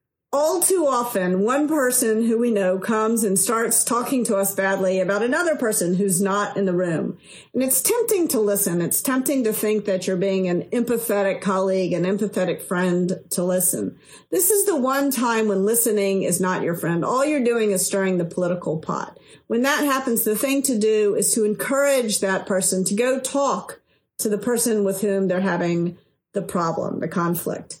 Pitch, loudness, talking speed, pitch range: 205 Hz, -21 LUFS, 190 wpm, 190-245 Hz